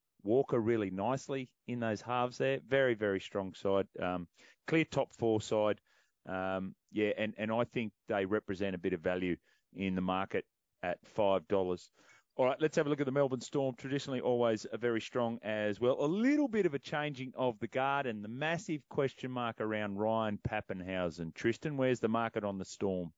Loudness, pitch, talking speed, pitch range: -35 LUFS, 115 Hz, 190 wpm, 100-130 Hz